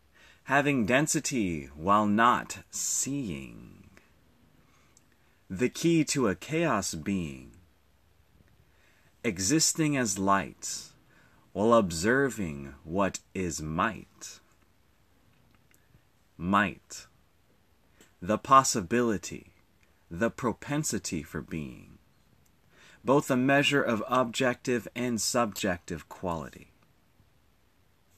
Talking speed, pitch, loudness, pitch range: 70 wpm, 105 Hz, -28 LUFS, 90-130 Hz